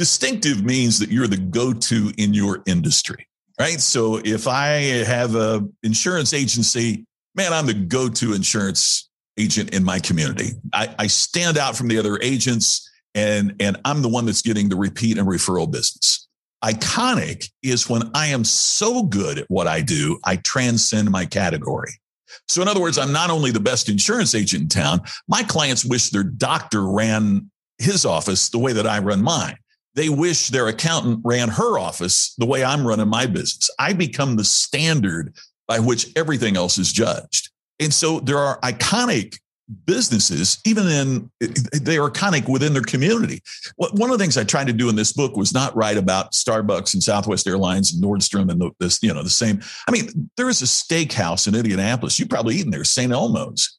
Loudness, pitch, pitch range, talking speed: -19 LUFS, 120 Hz, 105-145 Hz, 185 wpm